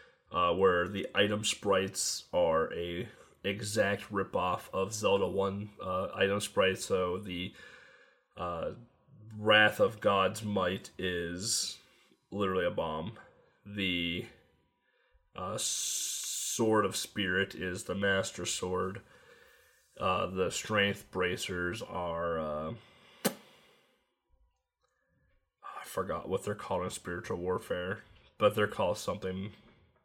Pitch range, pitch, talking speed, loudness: 90-105 Hz, 100 Hz, 110 wpm, -32 LUFS